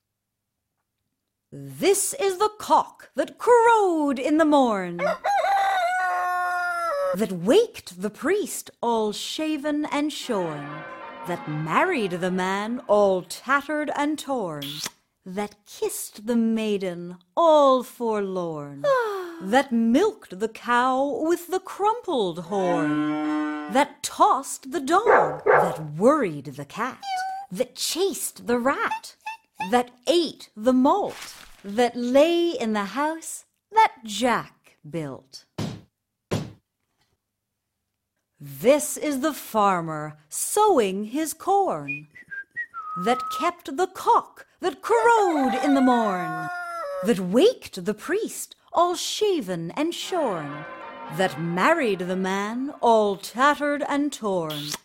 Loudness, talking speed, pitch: -24 LUFS, 105 wpm, 250 Hz